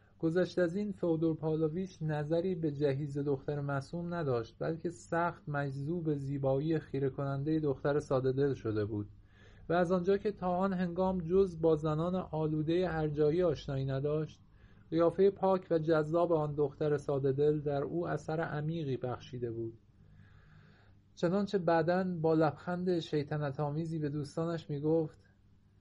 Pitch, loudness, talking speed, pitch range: 155 Hz, -33 LUFS, 135 wpm, 140-170 Hz